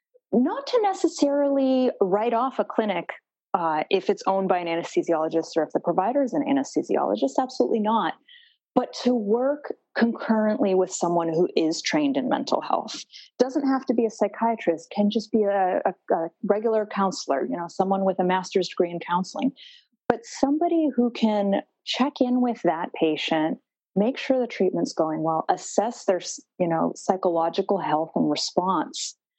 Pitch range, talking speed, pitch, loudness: 180-265 Hz, 165 wpm, 215 Hz, -24 LUFS